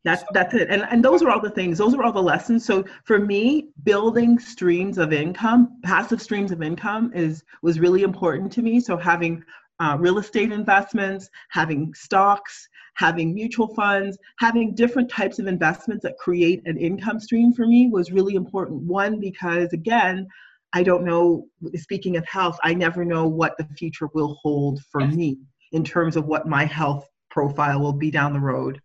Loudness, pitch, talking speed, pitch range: -21 LUFS, 180 Hz, 185 wpm, 160-210 Hz